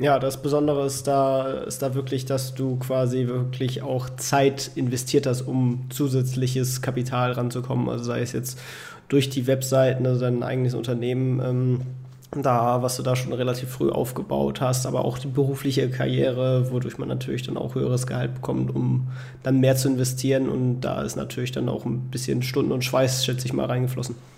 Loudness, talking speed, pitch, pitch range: -24 LUFS, 185 wpm, 130 Hz, 125-130 Hz